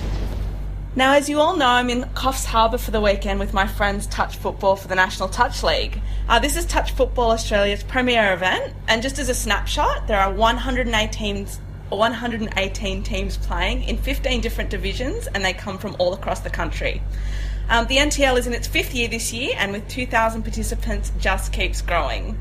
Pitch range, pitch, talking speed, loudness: 195-250 Hz, 225 Hz, 185 wpm, -21 LUFS